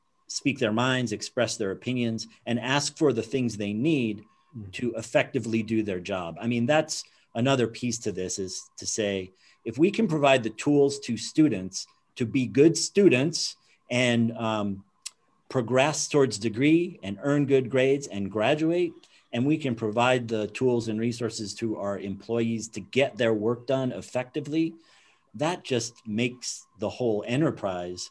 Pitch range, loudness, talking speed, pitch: 110-140 Hz, -26 LUFS, 160 wpm, 120 Hz